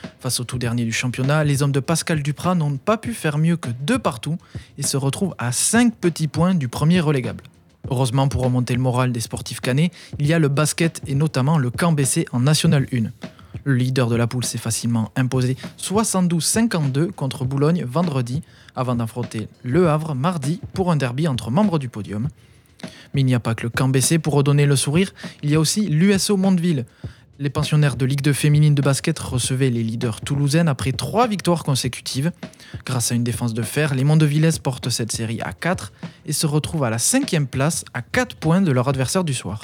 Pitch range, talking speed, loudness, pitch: 125-160 Hz, 205 wpm, -20 LUFS, 140 Hz